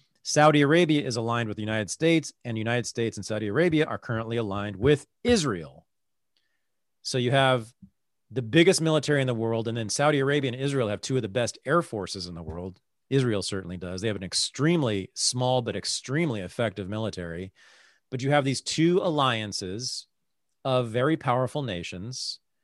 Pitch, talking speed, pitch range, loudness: 120 Hz, 180 wpm, 105-145 Hz, -26 LUFS